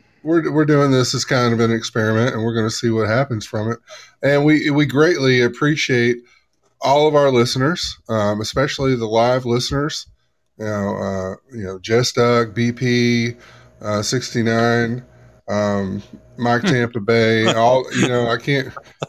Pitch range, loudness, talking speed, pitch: 115-130 Hz, -18 LUFS, 165 wpm, 120 Hz